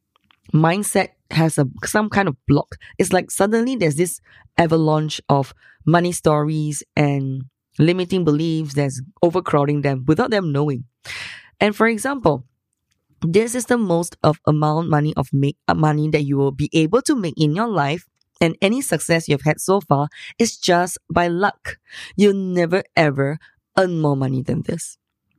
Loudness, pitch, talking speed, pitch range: -19 LUFS, 160 Hz, 160 wpm, 145-185 Hz